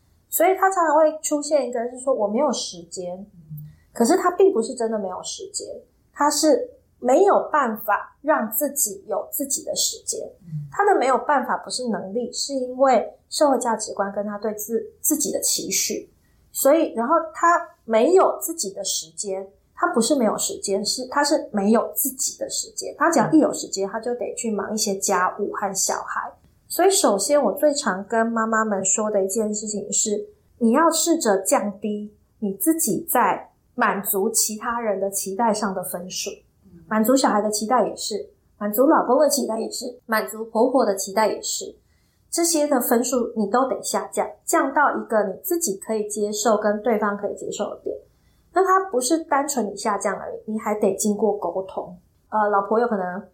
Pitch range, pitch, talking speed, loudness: 205-295 Hz, 230 Hz, 275 characters per minute, -22 LUFS